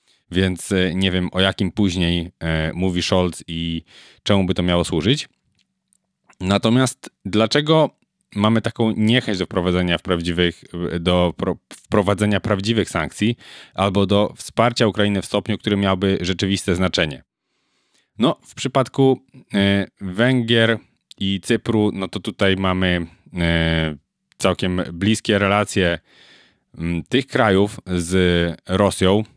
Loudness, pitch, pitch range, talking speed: -20 LUFS, 95 Hz, 90-110 Hz, 110 wpm